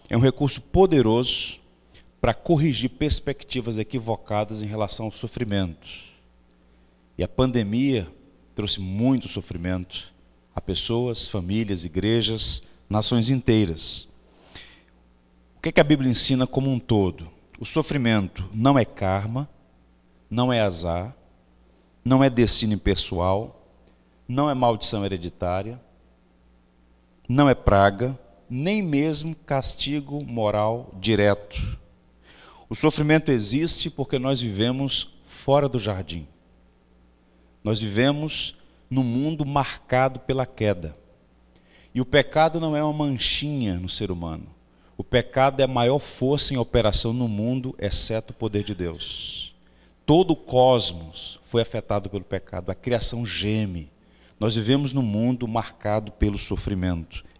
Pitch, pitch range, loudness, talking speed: 110 Hz, 85-130 Hz, -23 LUFS, 120 wpm